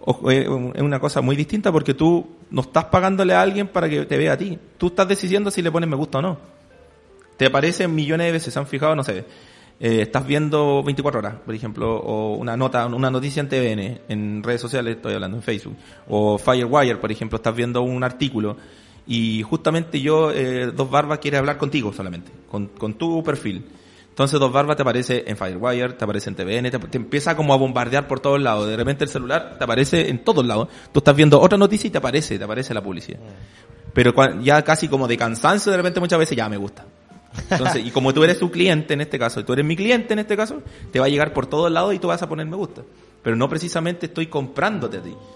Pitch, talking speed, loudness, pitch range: 140 Hz, 230 wpm, -20 LUFS, 115-160 Hz